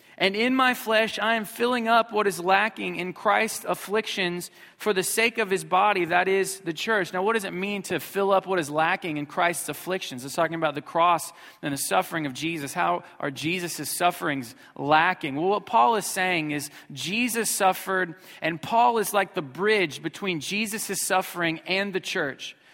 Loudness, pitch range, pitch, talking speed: -25 LUFS, 165-210 Hz, 185 Hz, 195 wpm